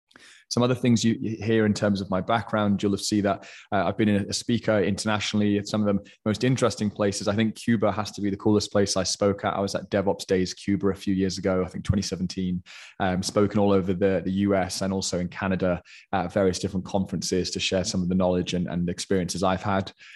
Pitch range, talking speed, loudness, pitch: 95-105 Hz, 230 wpm, -25 LUFS, 100 Hz